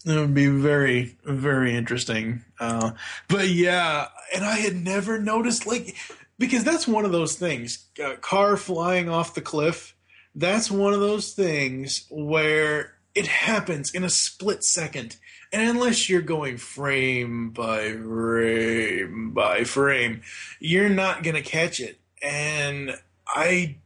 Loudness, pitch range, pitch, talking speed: -23 LUFS, 130-195 Hz, 155 Hz, 140 wpm